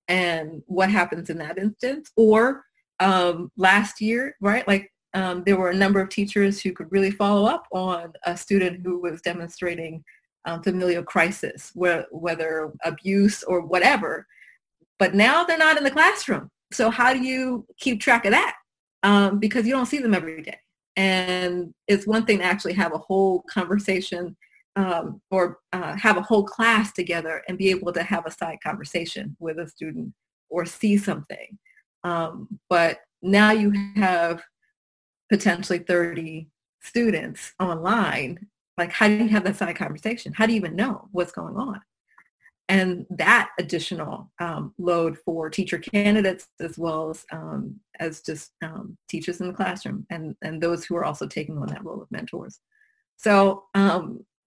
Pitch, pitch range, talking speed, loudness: 190 Hz, 175-210 Hz, 165 wpm, -23 LUFS